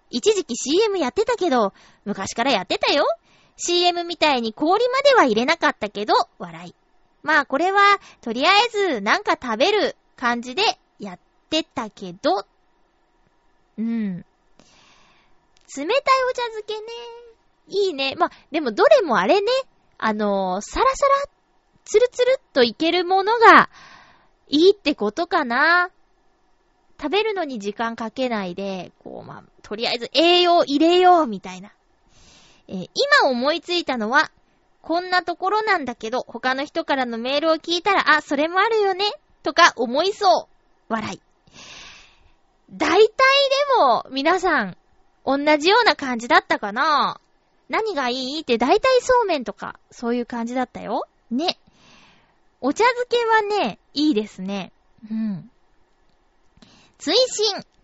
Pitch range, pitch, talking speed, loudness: 240-380 Hz, 310 Hz, 265 characters per minute, -20 LUFS